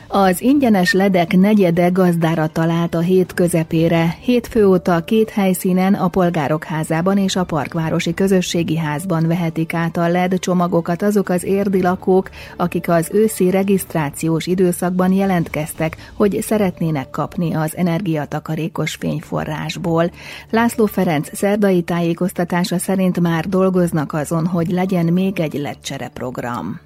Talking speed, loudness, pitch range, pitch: 125 wpm, -17 LUFS, 165-190 Hz, 180 Hz